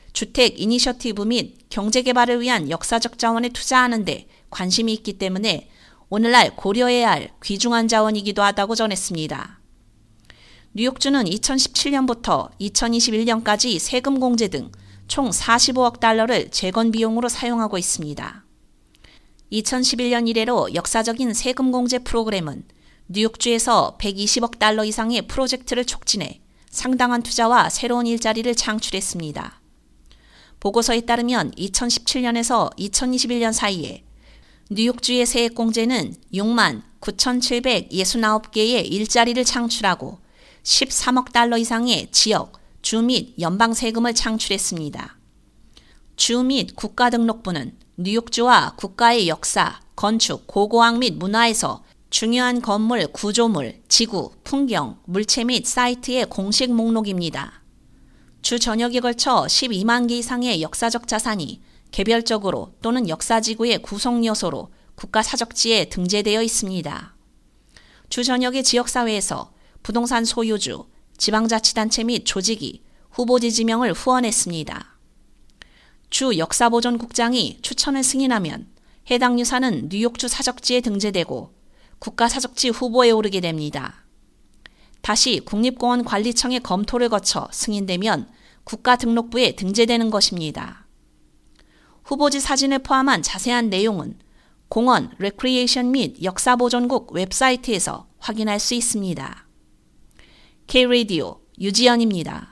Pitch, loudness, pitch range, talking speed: 230 Hz, -19 LUFS, 210-245 Hz, 275 characters per minute